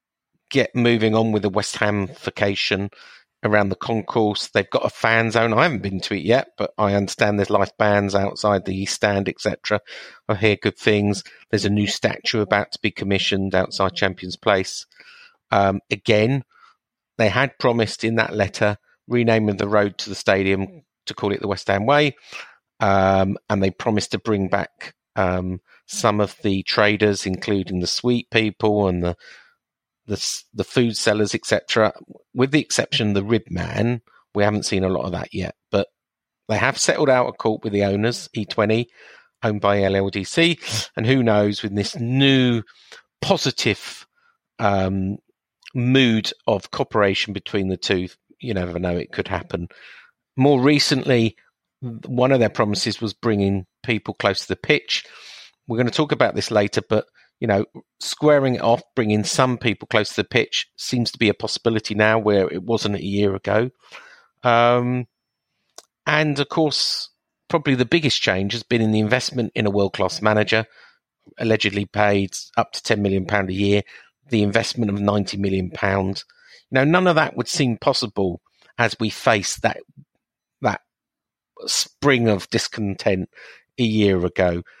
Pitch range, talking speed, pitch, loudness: 100-120 Hz, 165 wpm, 105 Hz, -20 LUFS